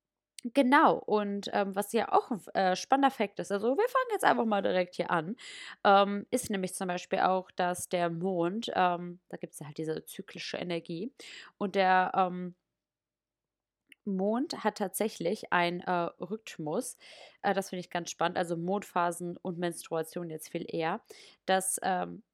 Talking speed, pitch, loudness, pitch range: 165 wpm, 185 Hz, -31 LUFS, 175-210 Hz